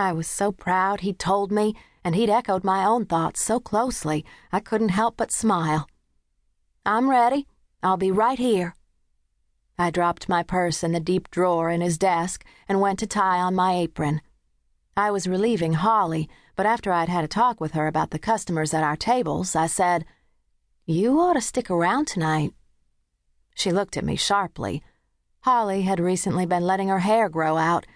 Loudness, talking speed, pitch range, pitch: -23 LUFS, 180 wpm, 165-210 Hz, 185 Hz